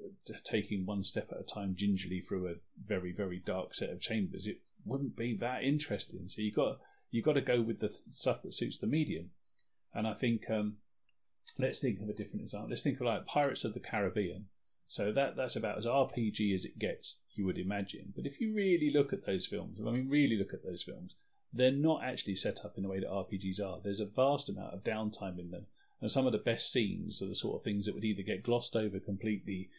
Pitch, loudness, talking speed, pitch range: 105 Hz, -36 LUFS, 235 wpm, 100-125 Hz